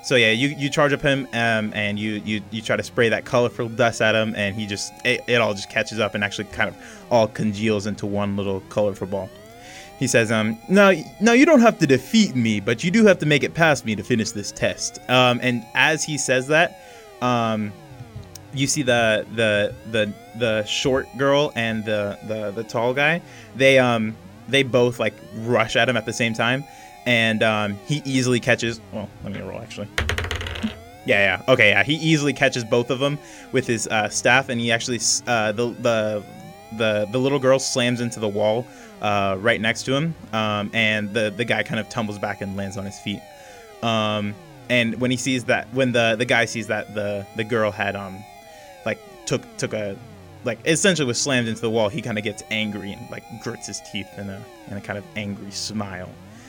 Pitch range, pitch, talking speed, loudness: 105-130 Hz, 115 Hz, 215 wpm, -21 LUFS